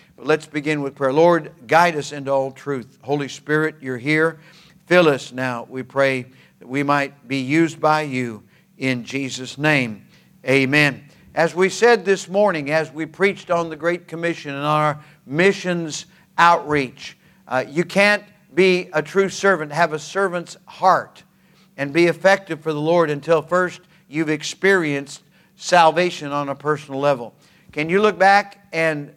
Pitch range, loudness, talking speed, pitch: 145-180 Hz, -19 LUFS, 165 wpm, 160 Hz